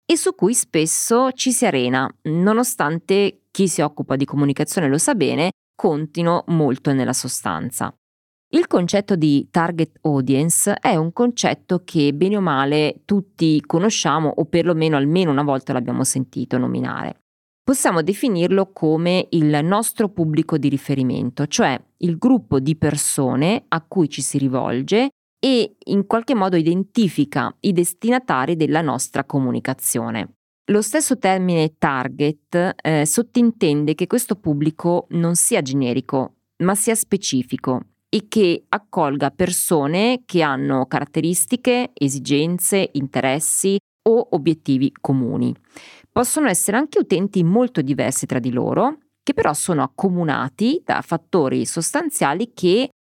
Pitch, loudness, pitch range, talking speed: 165 Hz, -19 LUFS, 140-200 Hz, 130 wpm